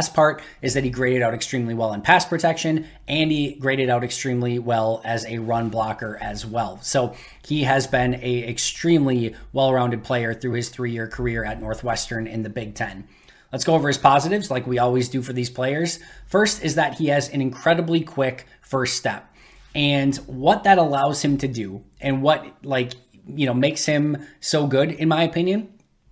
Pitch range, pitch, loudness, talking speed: 120-150 Hz, 130 Hz, -22 LUFS, 195 wpm